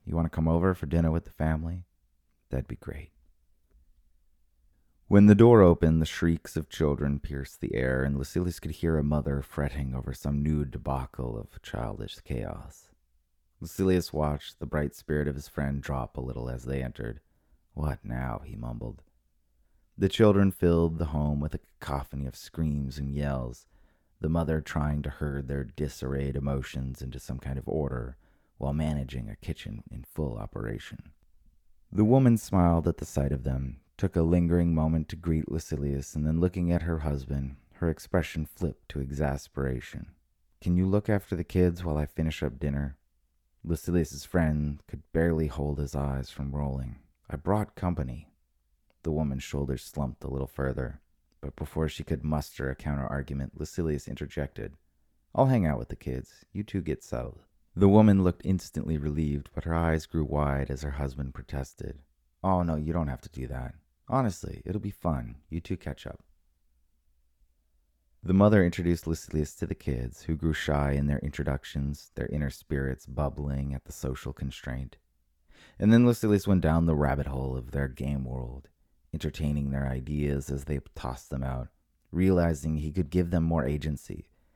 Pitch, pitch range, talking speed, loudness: 75 Hz, 65-80 Hz, 170 wpm, -29 LUFS